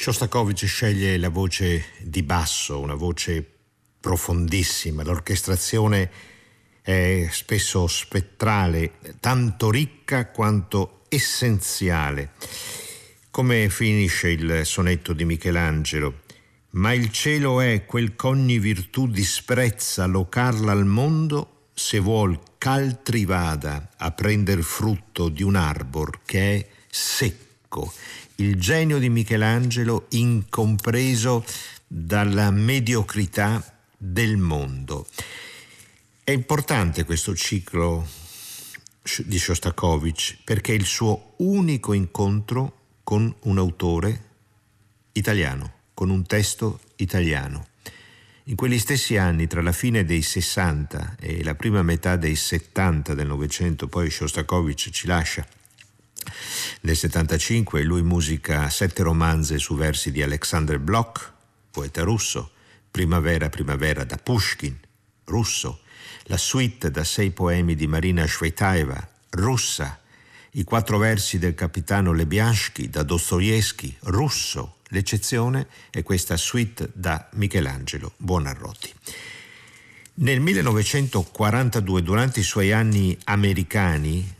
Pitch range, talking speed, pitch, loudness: 85-110 Hz, 105 wpm, 100 Hz, -23 LUFS